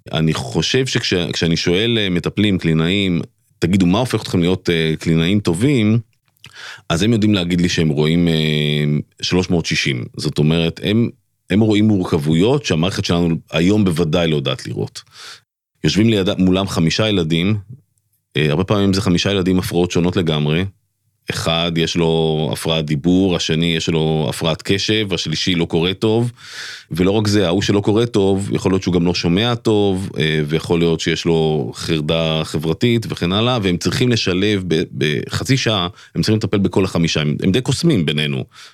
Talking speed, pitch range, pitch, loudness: 155 wpm, 80-105 Hz, 90 Hz, -17 LUFS